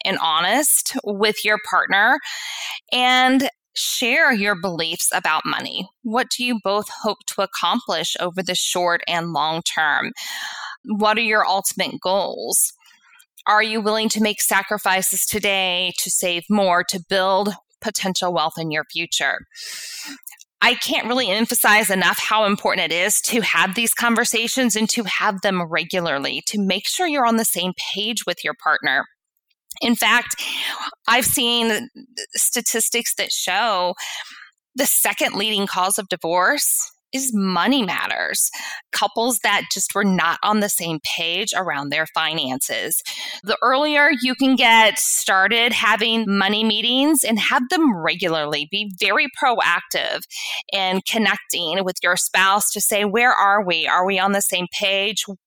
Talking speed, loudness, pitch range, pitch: 145 wpm, -18 LUFS, 185-240 Hz, 210 Hz